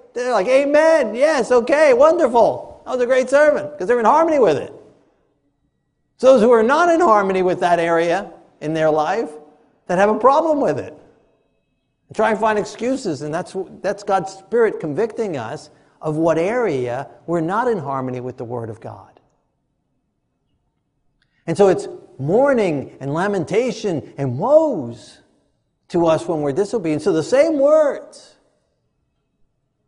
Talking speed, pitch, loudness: 155 wpm, 190 Hz, -17 LUFS